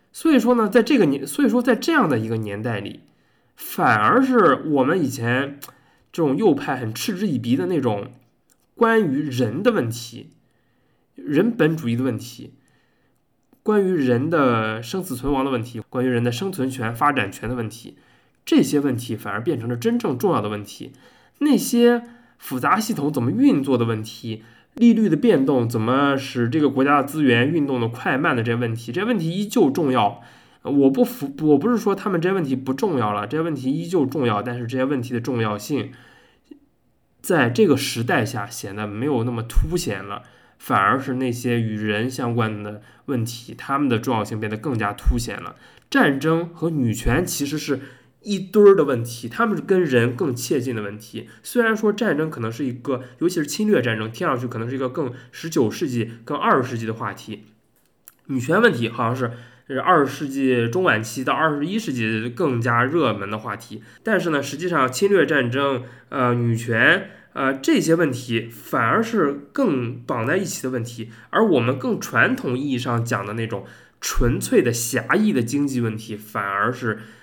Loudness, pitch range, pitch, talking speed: -21 LUFS, 115-155 Hz, 125 Hz, 280 characters per minute